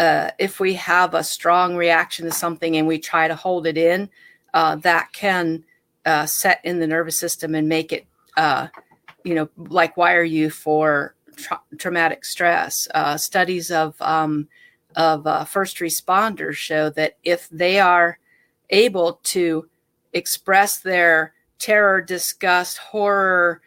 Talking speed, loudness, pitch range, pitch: 150 wpm, -19 LUFS, 160-185 Hz, 170 Hz